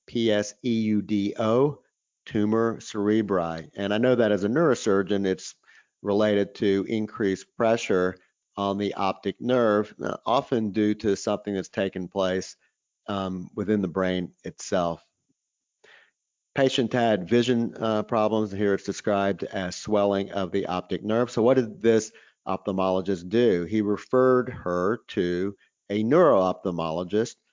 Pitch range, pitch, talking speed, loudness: 95-110 Hz, 105 Hz, 125 wpm, -25 LUFS